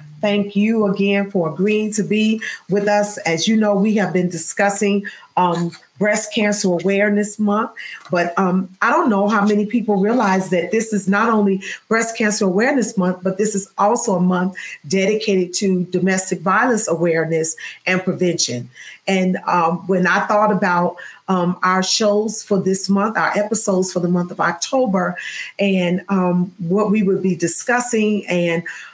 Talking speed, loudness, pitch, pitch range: 165 wpm, -17 LUFS, 195 Hz, 180-210 Hz